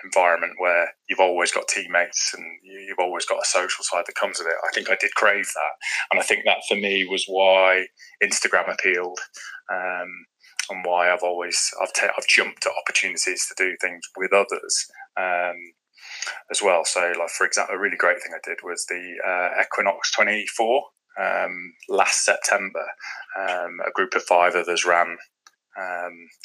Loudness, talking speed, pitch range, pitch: -22 LUFS, 180 wpm, 90-95 Hz, 90 Hz